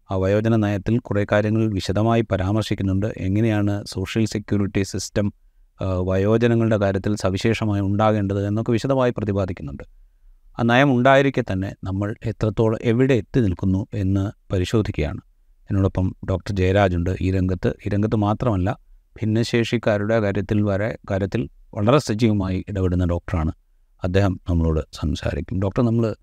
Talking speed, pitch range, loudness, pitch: 110 wpm, 95-110 Hz, -21 LUFS, 100 Hz